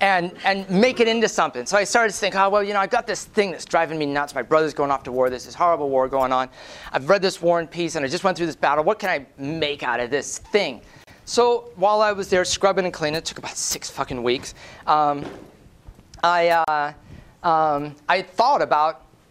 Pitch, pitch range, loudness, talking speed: 165 Hz, 145-195 Hz, -21 LUFS, 240 wpm